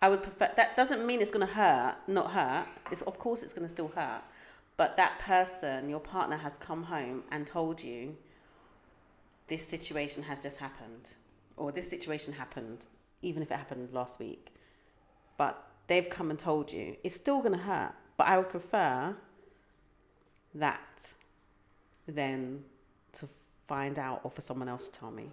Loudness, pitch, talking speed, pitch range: -33 LUFS, 150 Hz, 165 wpm, 125-175 Hz